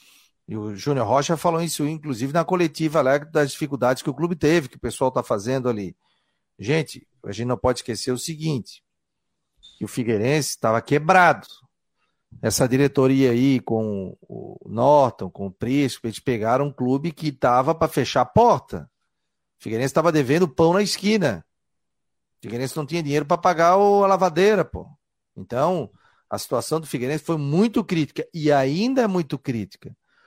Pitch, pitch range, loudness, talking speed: 145 Hz, 125-165 Hz, -21 LUFS, 165 wpm